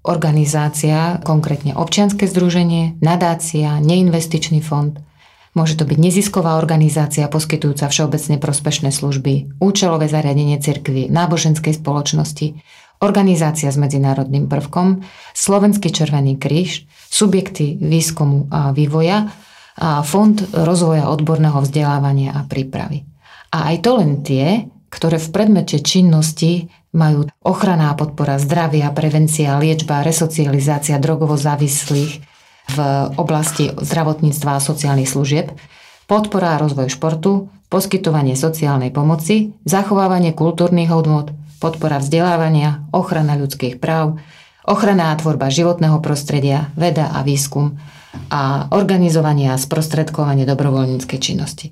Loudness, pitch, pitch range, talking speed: -16 LUFS, 155 Hz, 145-170 Hz, 105 wpm